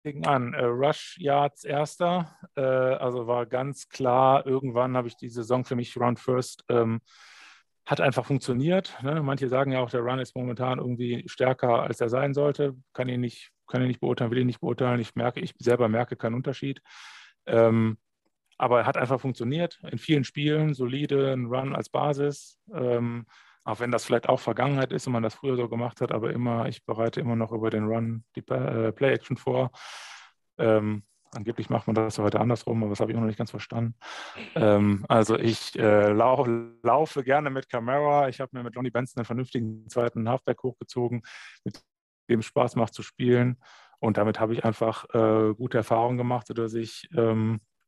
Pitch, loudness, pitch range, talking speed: 125 Hz, -26 LUFS, 115-130 Hz, 185 wpm